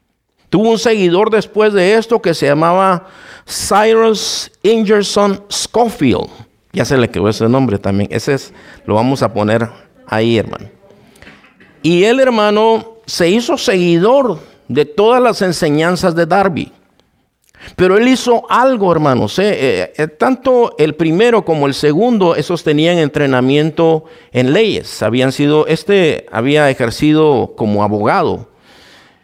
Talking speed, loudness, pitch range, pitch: 135 wpm, -12 LUFS, 135-215 Hz, 165 Hz